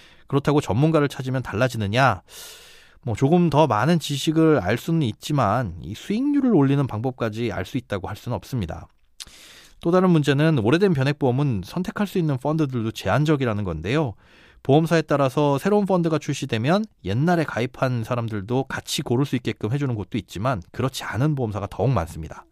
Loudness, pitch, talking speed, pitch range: -22 LUFS, 135 Hz, 390 characters per minute, 115-155 Hz